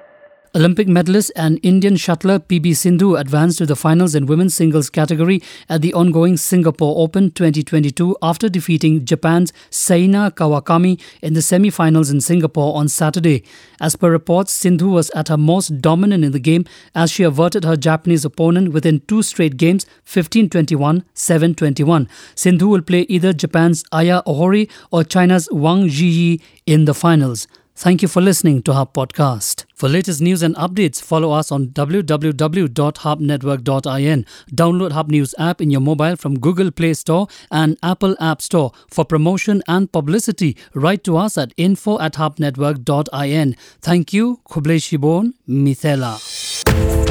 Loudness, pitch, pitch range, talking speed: -15 LUFS, 165 Hz, 155-180 Hz, 150 wpm